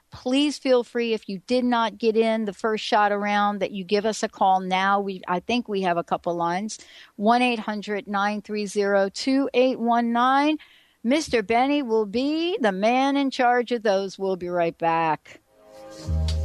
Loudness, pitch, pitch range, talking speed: -23 LUFS, 215 Hz, 190-245 Hz, 170 wpm